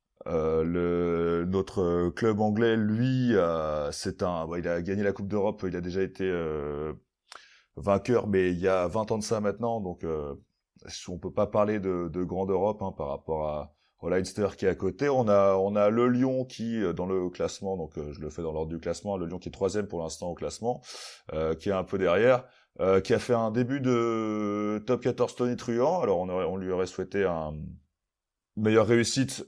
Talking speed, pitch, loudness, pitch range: 220 wpm, 95 Hz, -28 LUFS, 85-110 Hz